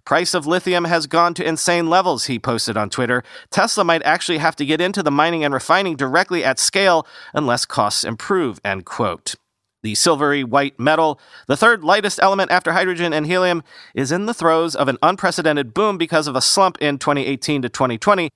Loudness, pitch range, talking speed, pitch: -17 LUFS, 140-180 Hz, 195 wpm, 165 Hz